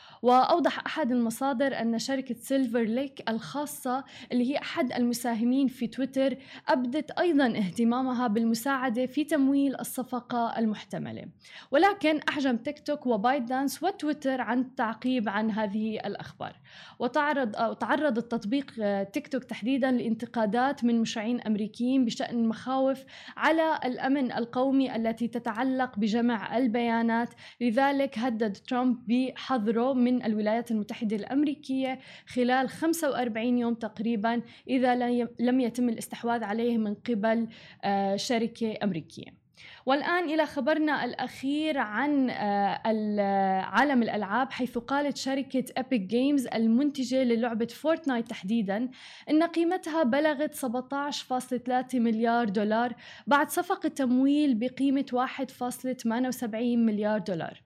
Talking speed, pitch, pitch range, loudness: 105 wpm, 250 Hz, 230-270 Hz, -28 LUFS